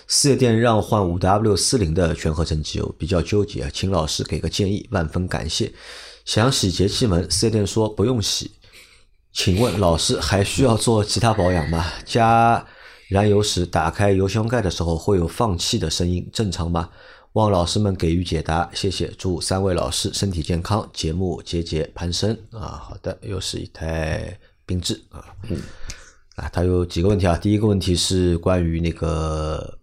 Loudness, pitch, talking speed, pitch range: -21 LUFS, 95 Hz, 260 characters per minute, 85-105 Hz